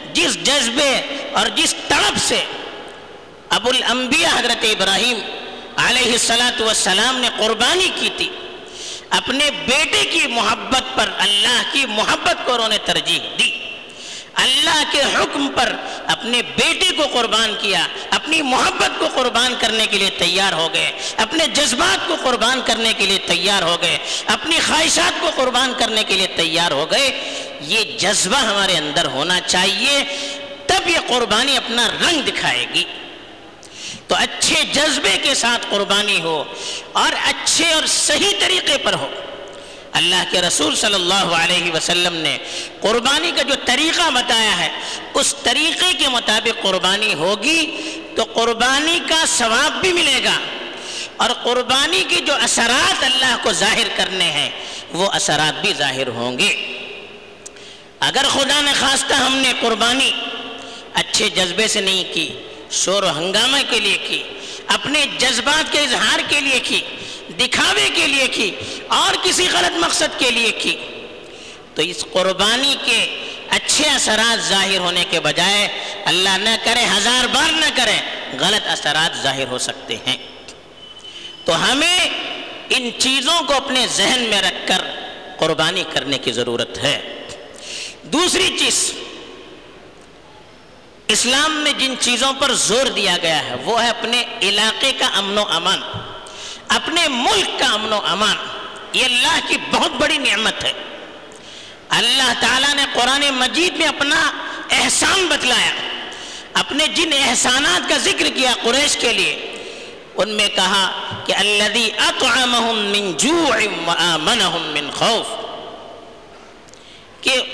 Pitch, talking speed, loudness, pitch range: 240 Hz, 140 wpm, -15 LUFS, 200-290 Hz